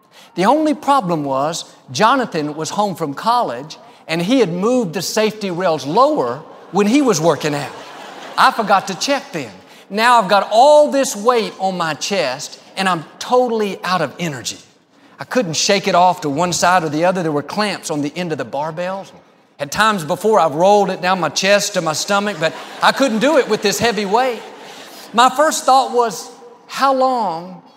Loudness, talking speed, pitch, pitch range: -16 LUFS, 190 wpm, 200 Hz, 170-240 Hz